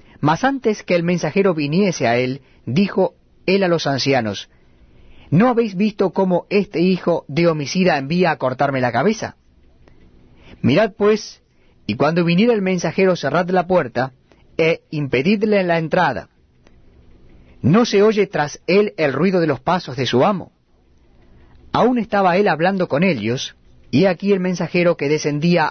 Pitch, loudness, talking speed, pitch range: 170 Hz, -18 LUFS, 150 wpm, 130-195 Hz